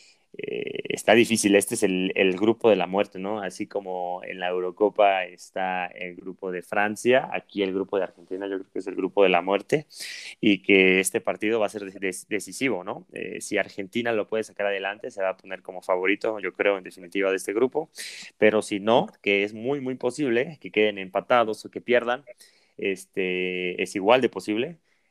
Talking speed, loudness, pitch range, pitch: 205 wpm, -25 LUFS, 95-110 Hz, 100 Hz